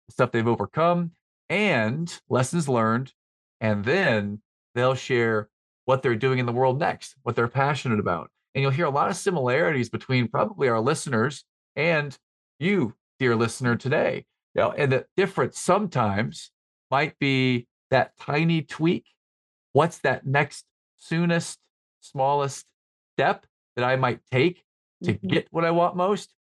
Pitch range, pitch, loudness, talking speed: 115-155 Hz, 130 Hz, -24 LUFS, 145 wpm